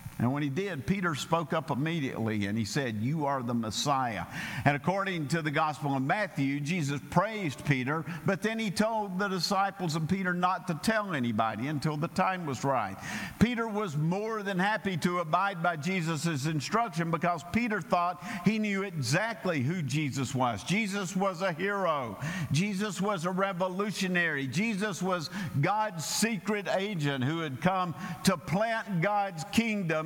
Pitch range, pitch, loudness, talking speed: 145-195 Hz, 175 Hz, -30 LUFS, 160 wpm